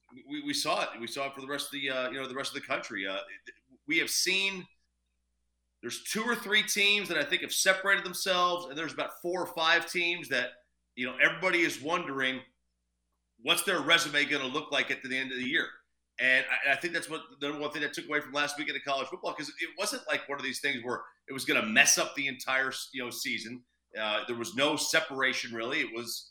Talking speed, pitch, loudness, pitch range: 245 wpm, 145 Hz, -29 LUFS, 125-175 Hz